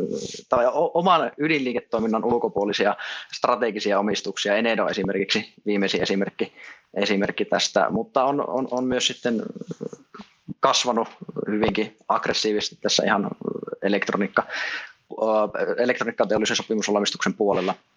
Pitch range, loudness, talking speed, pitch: 105-125 Hz, -23 LUFS, 95 wpm, 110 Hz